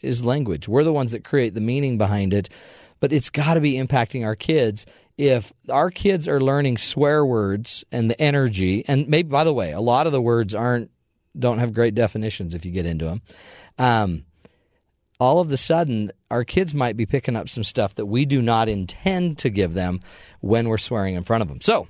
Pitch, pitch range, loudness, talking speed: 120 Hz, 105-135 Hz, -21 LUFS, 215 wpm